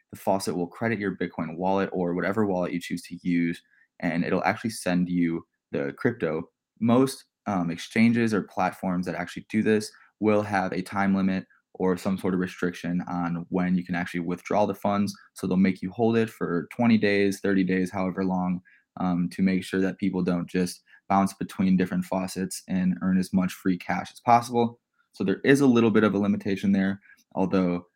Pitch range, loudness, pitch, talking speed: 90-105 Hz, -26 LUFS, 95 Hz, 195 wpm